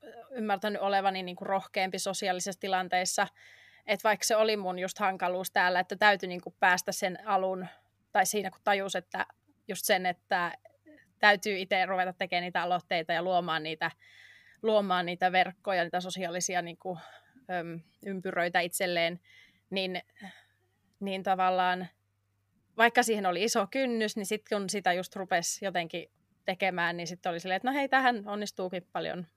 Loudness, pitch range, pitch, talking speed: -30 LUFS, 180-205 Hz, 185 Hz, 150 wpm